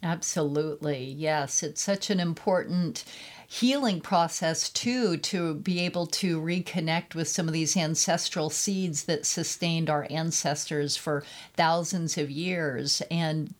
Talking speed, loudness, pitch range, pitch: 130 wpm, -28 LUFS, 155-180 Hz, 165 Hz